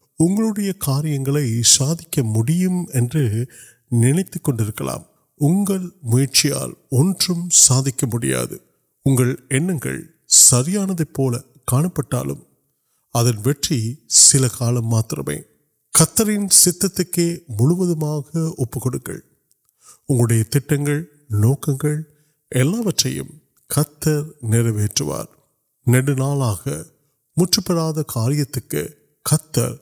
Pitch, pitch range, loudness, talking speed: 145 Hz, 125-160 Hz, -18 LUFS, 40 wpm